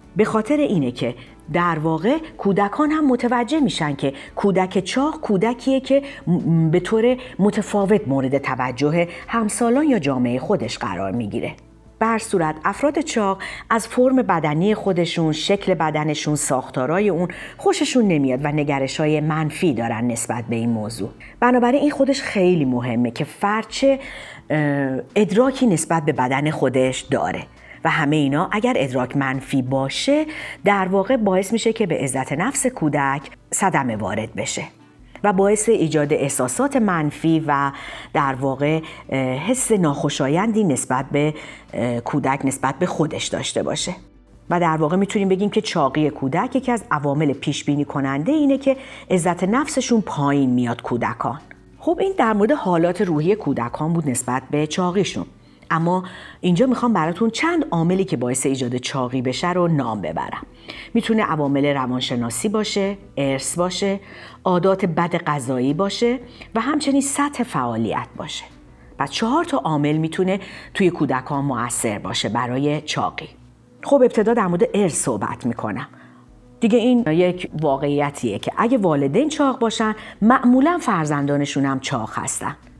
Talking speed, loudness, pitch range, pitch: 140 wpm, -20 LUFS, 135-220 Hz, 165 Hz